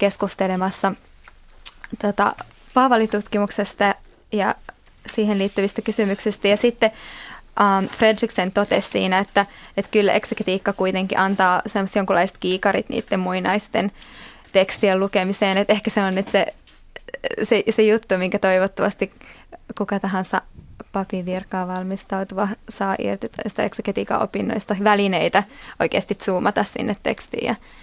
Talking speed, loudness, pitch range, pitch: 110 wpm, -21 LUFS, 190-215 Hz, 200 Hz